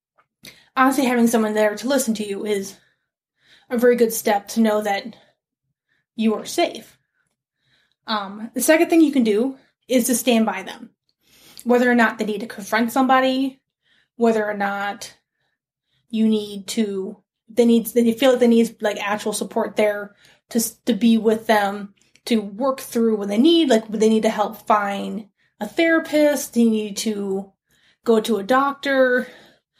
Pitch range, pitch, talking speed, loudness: 210-245 Hz, 225 Hz, 165 wpm, -20 LUFS